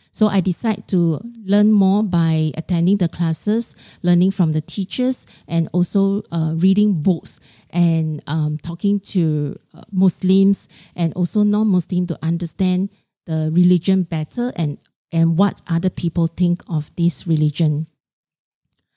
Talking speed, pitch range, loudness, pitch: 135 wpm, 165-195 Hz, -19 LUFS, 175 Hz